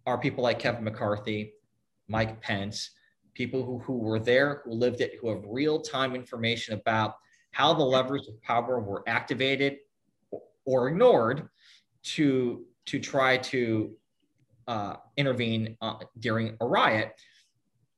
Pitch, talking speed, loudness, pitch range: 120 Hz, 135 wpm, -28 LUFS, 110-130 Hz